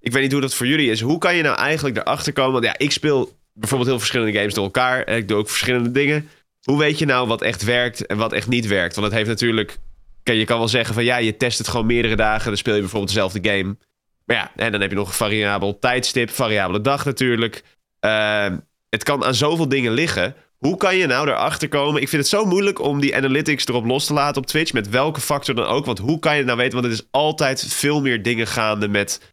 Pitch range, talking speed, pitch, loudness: 110-140 Hz, 260 wpm, 125 Hz, -19 LUFS